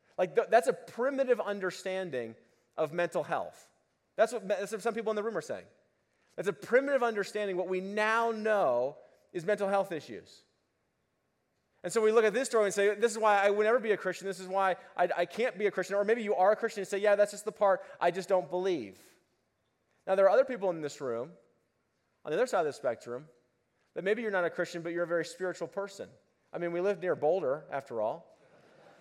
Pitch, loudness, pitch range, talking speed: 200 Hz, -31 LUFS, 180-220 Hz, 235 wpm